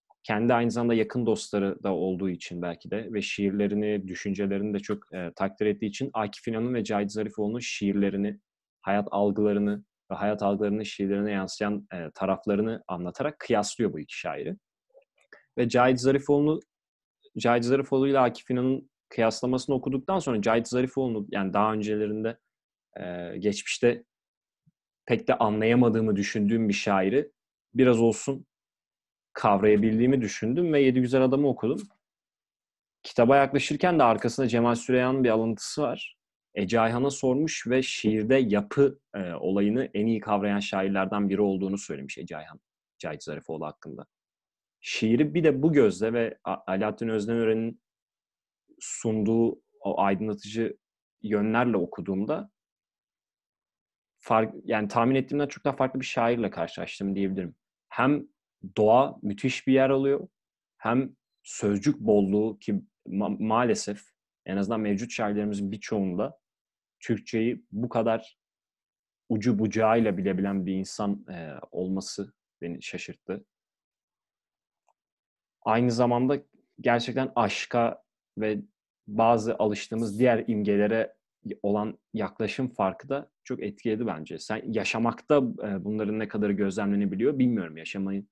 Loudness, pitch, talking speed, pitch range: -27 LUFS, 110 Hz, 120 wpm, 100-125 Hz